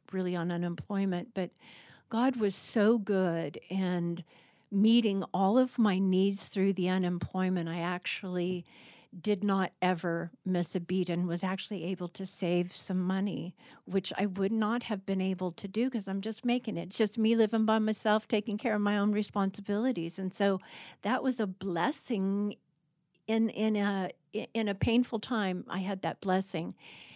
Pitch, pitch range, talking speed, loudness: 195 Hz, 180-215 Hz, 170 wpm, -31 LUFS